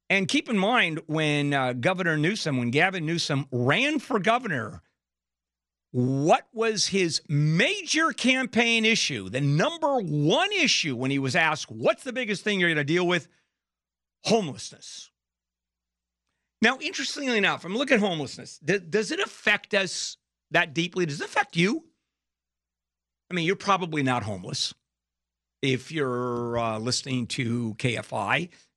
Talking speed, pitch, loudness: 140 wpm, 155 Hz, -25 LUFS